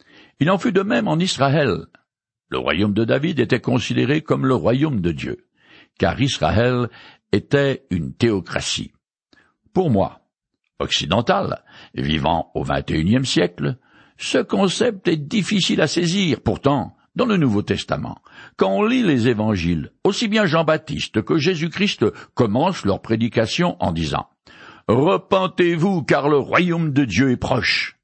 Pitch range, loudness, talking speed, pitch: 115-180 Hz, -20 LUFS, 135 wpm, 140 Hz